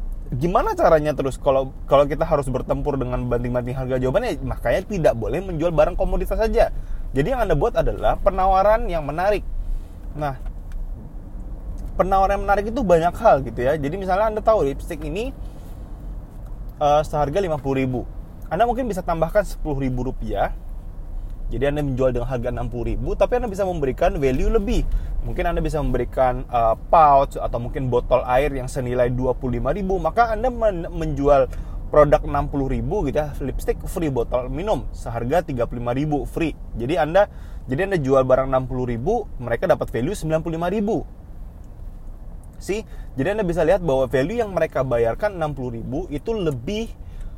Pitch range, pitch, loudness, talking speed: 125-175 Hz, 140 Hz, -21 LUFS, 160 wpm